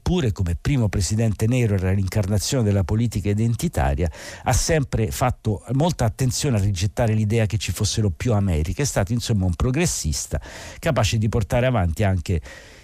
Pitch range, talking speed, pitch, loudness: 100-120 Hz, 155 wpm, 110 Hz, -22 LUFS